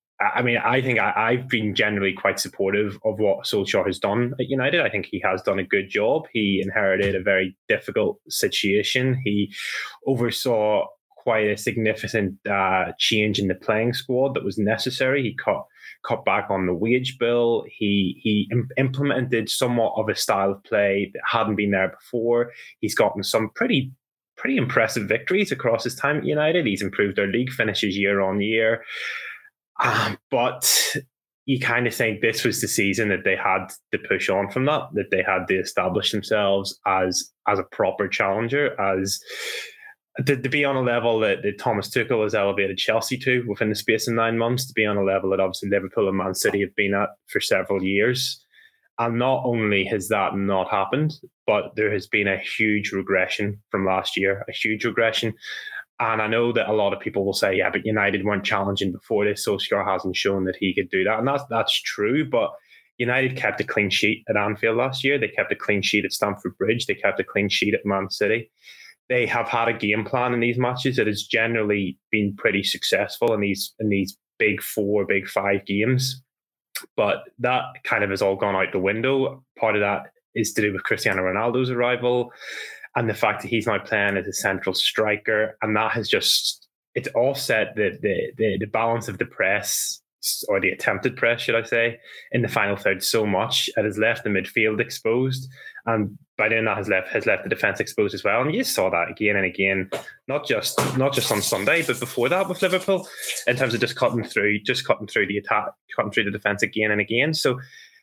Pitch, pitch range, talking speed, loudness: 110 Hz, 100-125 Hz, 205 wpm, -22 LUFS